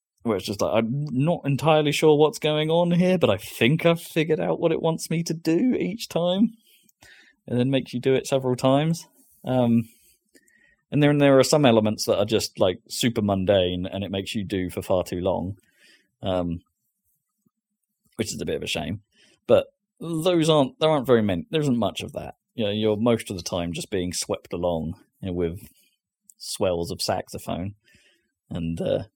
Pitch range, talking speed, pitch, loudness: 100-165 Hz, 195 wpm, 135 Hz, -23 LUFS